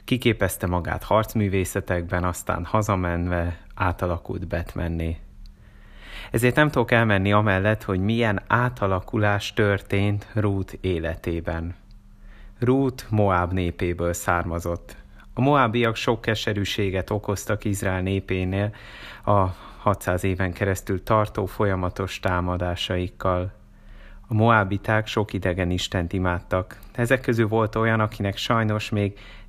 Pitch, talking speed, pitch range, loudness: 100 Hz, 100 wpm, 90-110 Hz, -24 LUFS